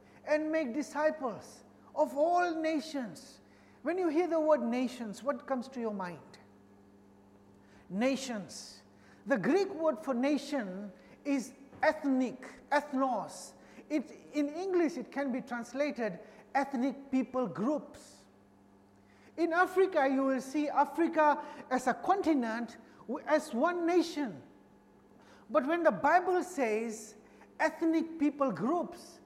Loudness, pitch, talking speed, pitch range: -32 LUFS, 275 Hz, 115 wpm, 225-310 Hz